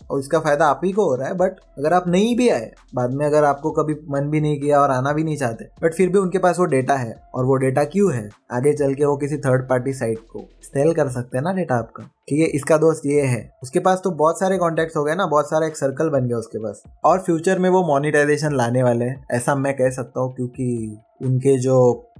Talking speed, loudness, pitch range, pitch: 260 wpm, -20 LUFS, 130-160 Hz, 145 Hz